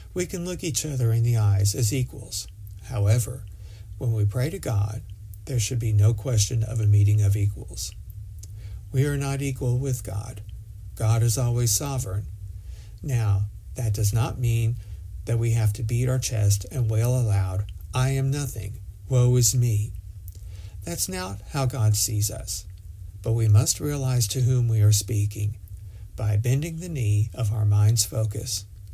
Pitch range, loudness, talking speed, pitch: 100-120 Hz, -24 LUFS, 165 wpm, 105 Hz